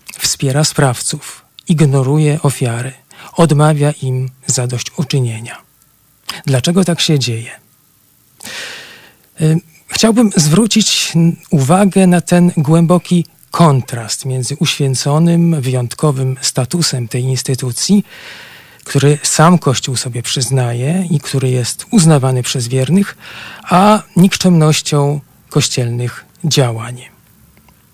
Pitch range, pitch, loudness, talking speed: 130-170 Hz, 145 Hz, -13 LUFS, 85 wpm